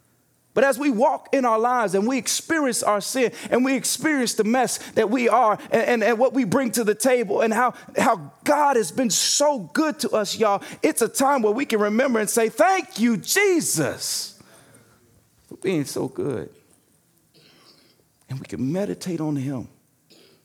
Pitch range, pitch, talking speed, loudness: 210-270 Hz, 240 Hz, 180 wpm, -21 LUFS